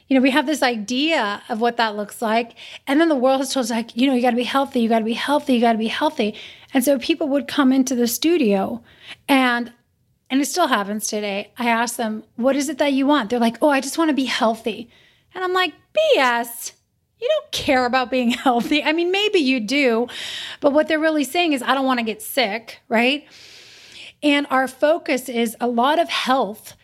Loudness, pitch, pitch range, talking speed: -20 LUFS, 260 Hz, 235-295 Hz, 230 wpm